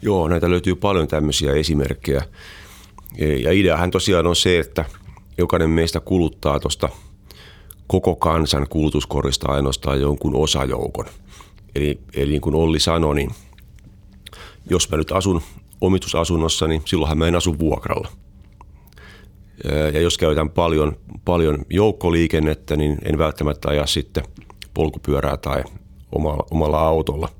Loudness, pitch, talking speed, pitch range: -20 LUFS, 80 Hz, 120 wpm, 75-90 Hz